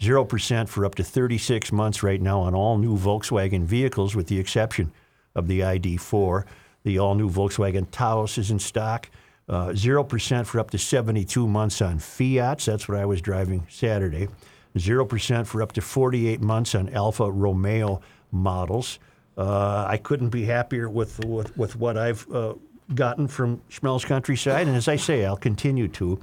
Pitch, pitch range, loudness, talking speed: 110 Hz, 100-120 Hz, -24 LUFS, 170 wpm